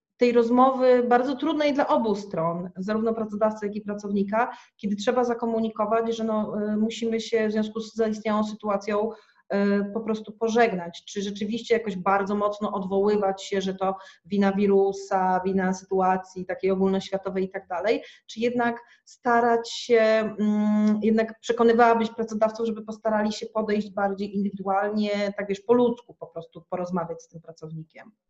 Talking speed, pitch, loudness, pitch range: 145 wpm, 210 Hz, -25 LUFS, 195-230 Hz